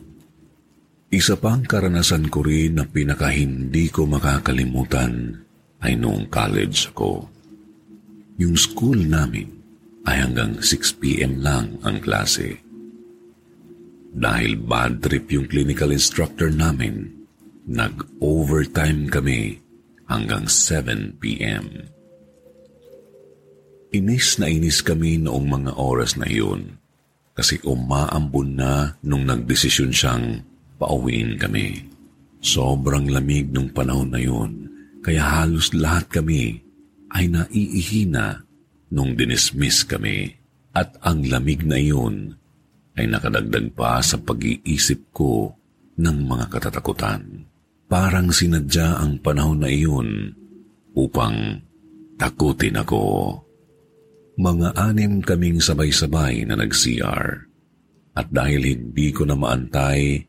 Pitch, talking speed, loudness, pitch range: 80 Hz, 100 wpm, -20 LUFS, 70-95 Hz